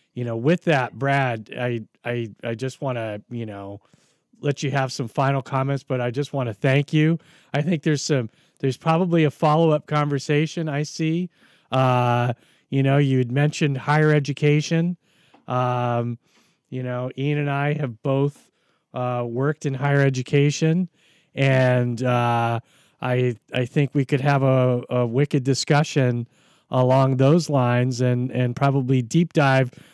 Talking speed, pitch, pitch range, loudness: 155 wpm, 135 Hz, 125-150 Hz, -22 LUFS